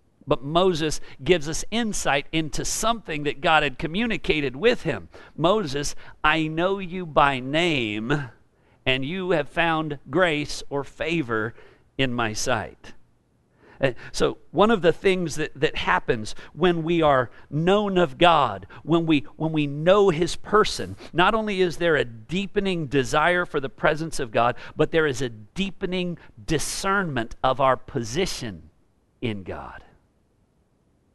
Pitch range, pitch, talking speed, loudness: 130-180 Hz, 155 Hz, 145 wpm, -23 LUFS